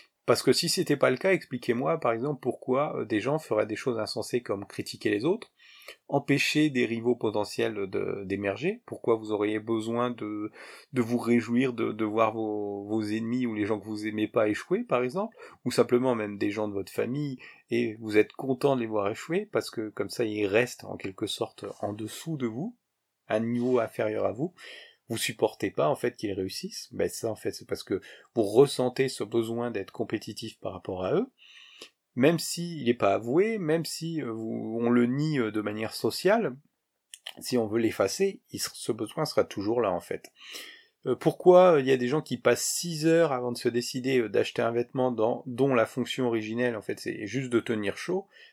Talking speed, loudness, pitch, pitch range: 200 wpm, -28 LUFS, 120 Hz, 110-145 Hz